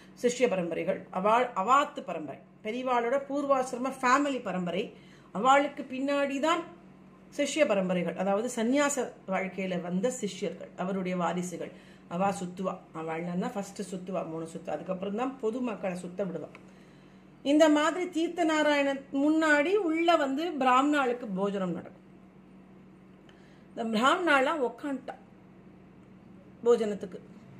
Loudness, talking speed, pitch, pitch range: -29 LUFS, 100 wpm, 230 Hz, 185-275 Hz